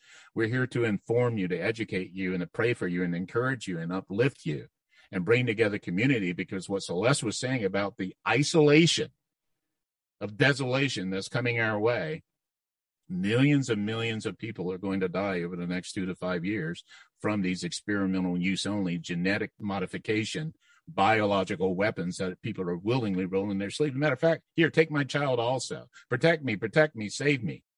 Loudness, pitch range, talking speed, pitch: -28 LUFS, 95-155 Hz, 180 wpm, 110 Hz